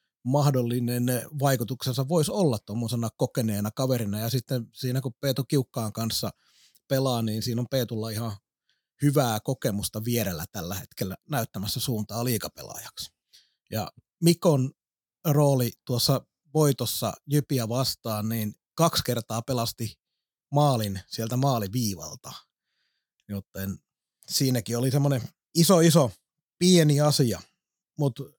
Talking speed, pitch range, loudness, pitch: 110 wpm, 115-140 Hz, -26 LUFS, 125 Hz